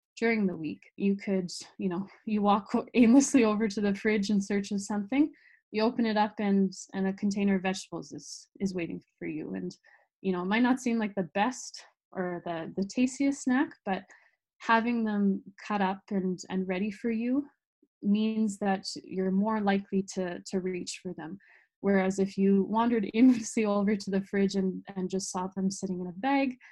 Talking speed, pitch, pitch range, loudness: 195 wpm, 200 Hz, 190-225 Hz, -29 LUFS